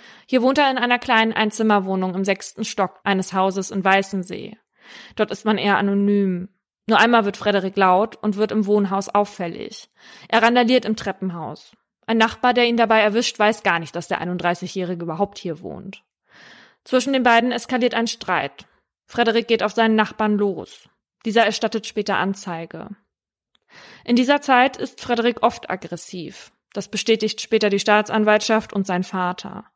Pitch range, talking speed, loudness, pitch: 190-225 Hz, 160 wpm, -19 LUFS, 210 Hz